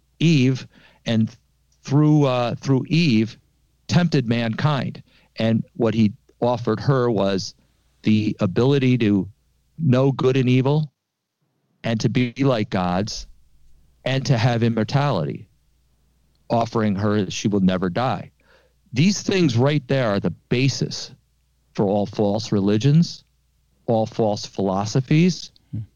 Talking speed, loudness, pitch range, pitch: 120 wpm, -21 LUFS, 100-135 Hz, 115 Hz